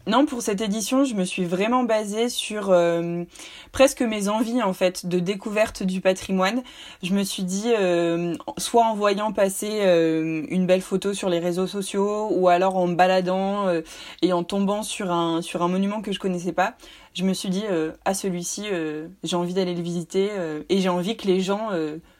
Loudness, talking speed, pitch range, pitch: -23 LUFS, 205 wpm, 175-210 Hz, 190 Hz